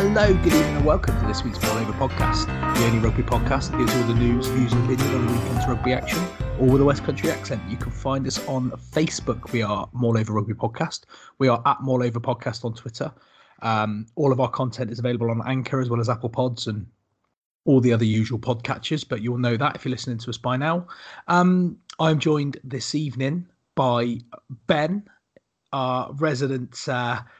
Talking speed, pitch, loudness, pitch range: 200 wpm, 125 Hz, -23 LUFS, 115-135 Hz